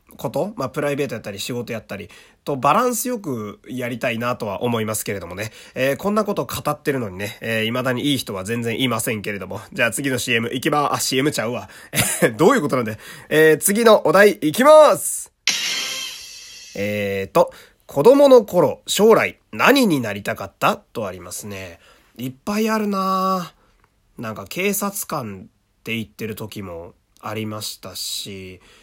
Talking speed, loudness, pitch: 345 characters per minute, -19 LUFS, 125 Hz